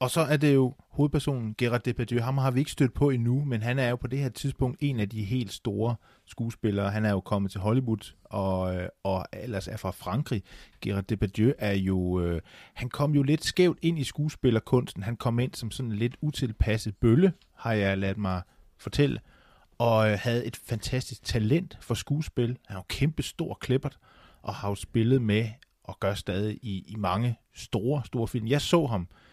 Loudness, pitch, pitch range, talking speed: -28 LUFS, 115 Hz, 105-135 Hz, 200 wpm